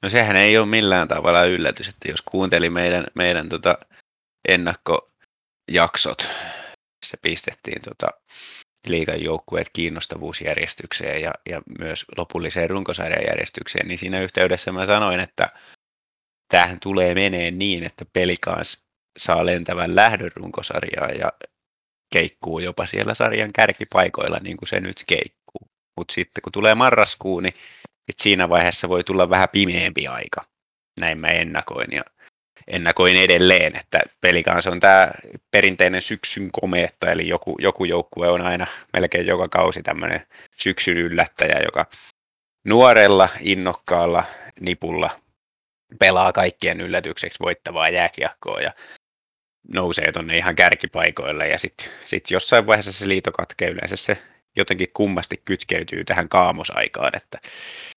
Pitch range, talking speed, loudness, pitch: 85-95 Hz, 125 wpm, -19 LUFS, 90 Hz